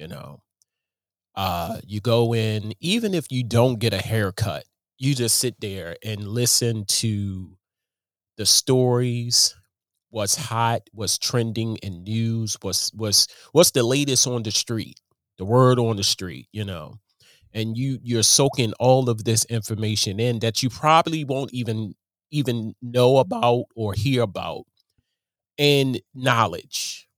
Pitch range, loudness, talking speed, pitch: 105-125 Hz, -21 LUFS, 145 wpm, 115 Hz